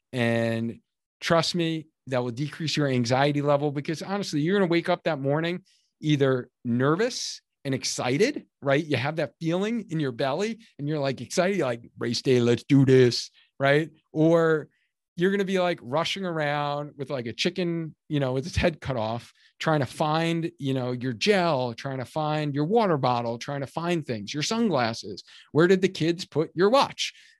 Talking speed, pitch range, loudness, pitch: 190 wpm, 130-170 Hz, -26 LUFS, 150 Hz